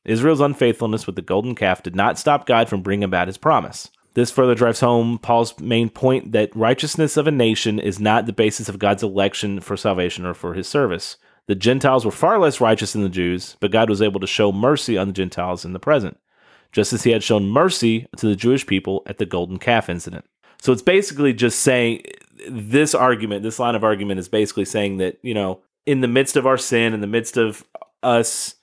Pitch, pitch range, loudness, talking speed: 110 Hz, 100-125 Hz, -19 LUFS, 220 wpm